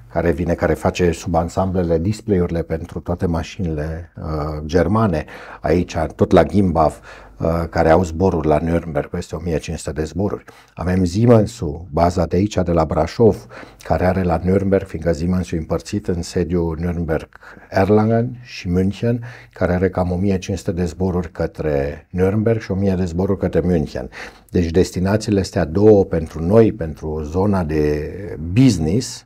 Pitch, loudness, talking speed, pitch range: 90 Hz, -19 LUFS, 150 wpm, 80-95 Hz